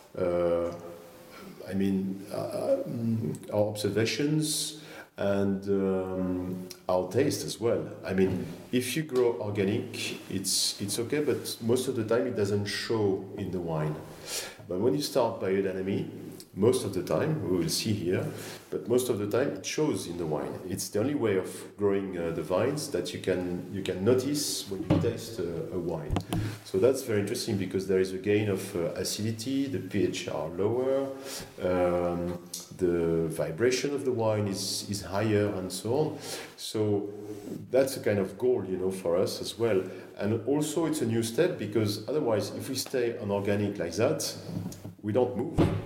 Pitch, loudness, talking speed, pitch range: 100 Hz, -30 LUFS, 175 wpm, 95-115 Hz